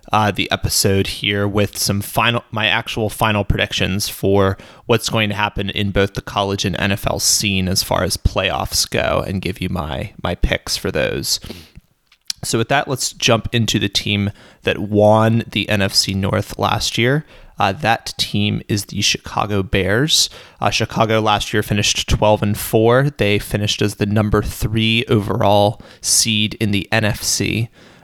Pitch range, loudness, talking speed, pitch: 100-110 Hz, -17 LUFS, 165 wpm, 105 Hz